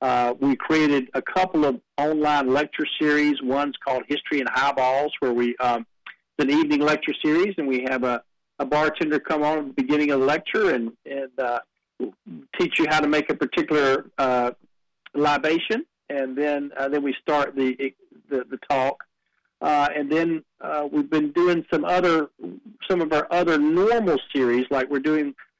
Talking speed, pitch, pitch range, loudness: 180 wpm, 145 Hz, 135-155 Hz, -23 LUFS